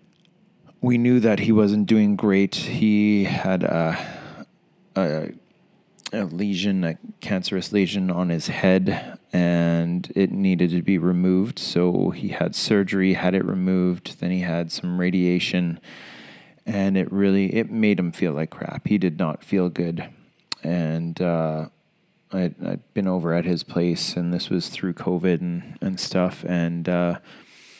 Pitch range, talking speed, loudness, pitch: 85-100 Hz, 155 wpm, -23 LUFS, 90 Hz